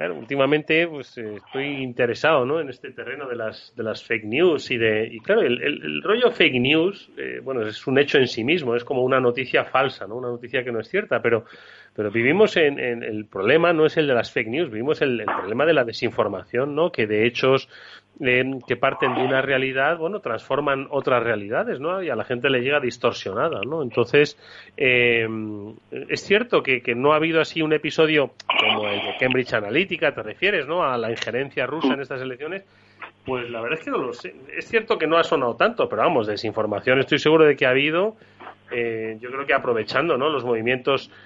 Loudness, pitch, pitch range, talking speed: -21 LUFS, 130 Hz, 115-150 Hz, 215 wpm